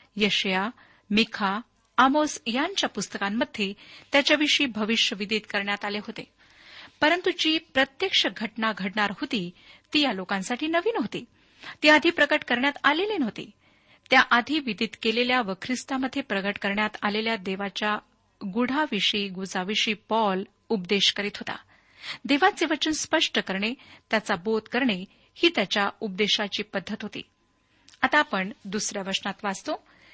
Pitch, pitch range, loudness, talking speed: 225 Hz, 205-285 Hz, -25 LUFS, 115 wpm